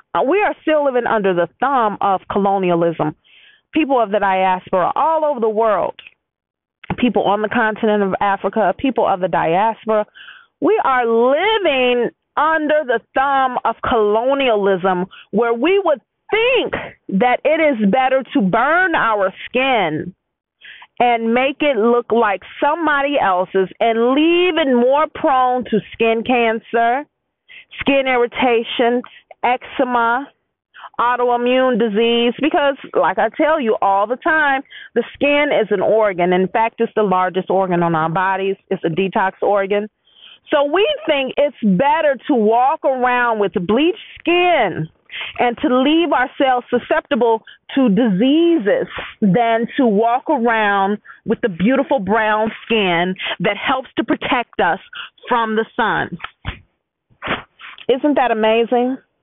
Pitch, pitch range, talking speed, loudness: 240 Hz, 210-285 Hz, 135 wpm, -16 LUFS